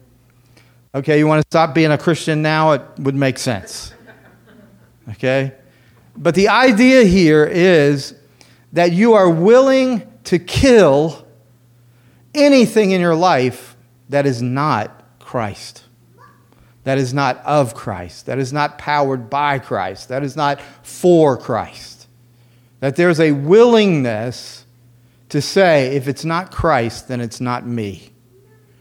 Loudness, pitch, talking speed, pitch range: -15 LUFS, 135 Hz, 130 wpm, 120-160 Hz